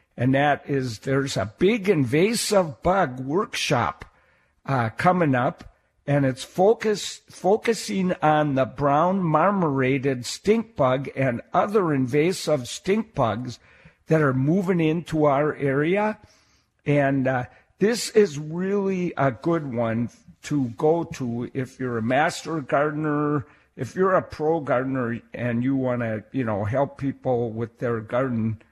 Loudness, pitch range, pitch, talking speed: -23 LUFS, 130-170 Hz, 140 Hz, 135 wpm